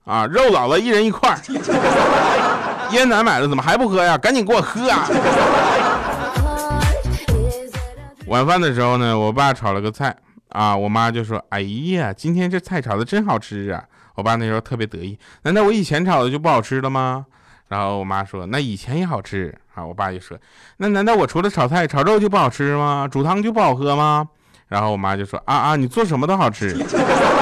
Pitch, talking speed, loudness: 130 Hz, 280 characters per minute, -18 LUFS